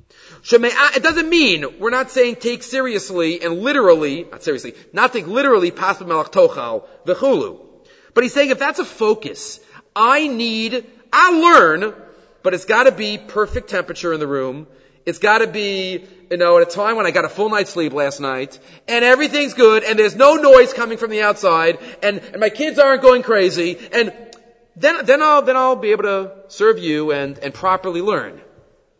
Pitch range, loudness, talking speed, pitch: 180-260 Hz, -15 LUFS, 190 wpm, 220 Hz